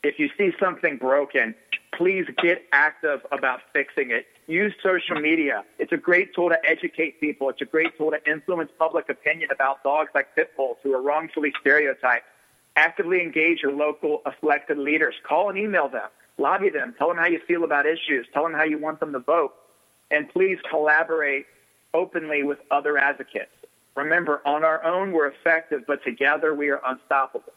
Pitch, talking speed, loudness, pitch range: 155 Hz, 180 wpm, -23 LUFS, 145-180 Hz